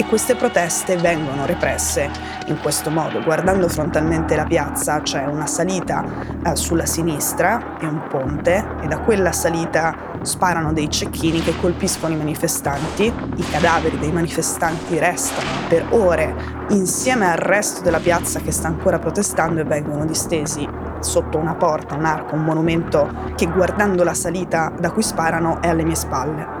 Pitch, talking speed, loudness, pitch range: 165 Hz, 155 wpm, -19 LUFS, 155-185 Hz